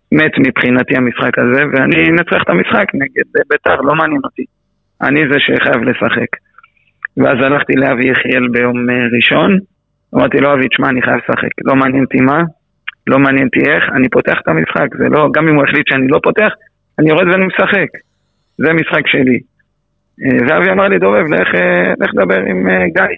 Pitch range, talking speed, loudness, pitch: 125-160 Hz, 175 wpm, -11 LUFS, 135 Hz